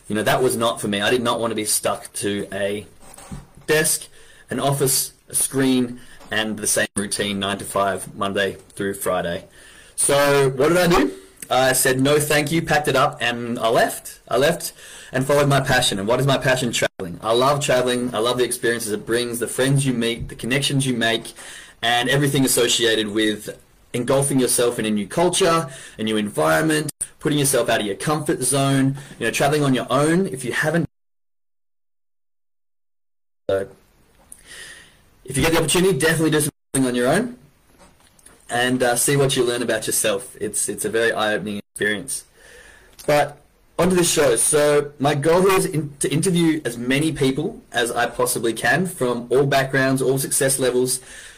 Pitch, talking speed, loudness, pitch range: 130 Hz, 180 wpm, -20 LUFS, 110-145 Hz